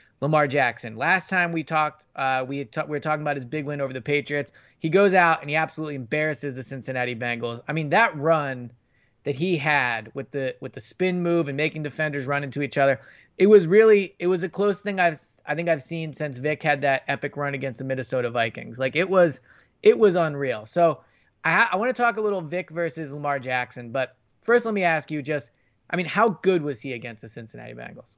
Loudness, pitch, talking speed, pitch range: -23 LUFS, 150 Hz, 230 wpm, 130-170 Hz